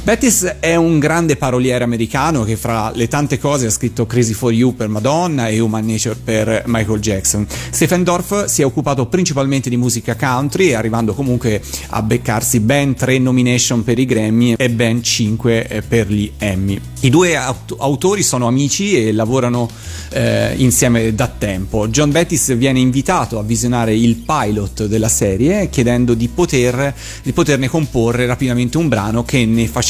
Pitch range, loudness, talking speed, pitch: 115-140 Hz, -15 LUFS, 165 wpm, 120 Hz